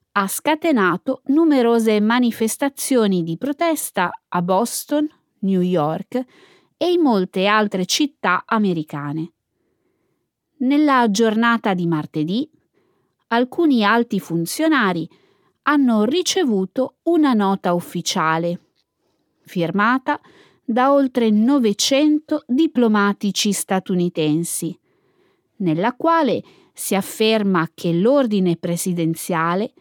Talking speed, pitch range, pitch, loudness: 85 wpm, 180-280 Hz, 220 Hz, -19 LUFS